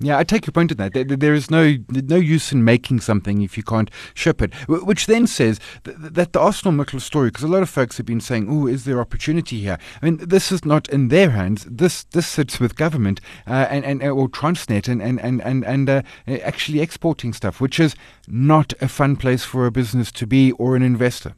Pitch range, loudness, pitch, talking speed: 120-155 Hz, -19 LUFS, 135 Hz, 225 wpm